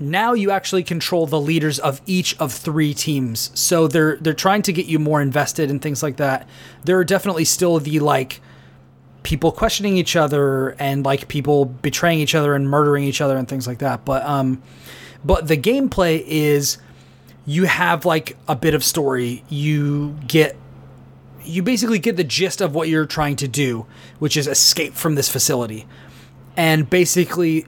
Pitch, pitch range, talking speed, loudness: 150 Hz, 135-165 Hz, 180 wpm, -18 LUFS